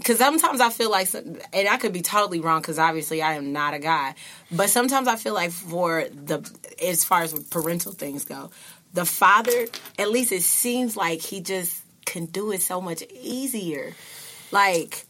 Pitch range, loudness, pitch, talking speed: 165-230 Hz, -23 LUFS, 180 Hz, 185 wpm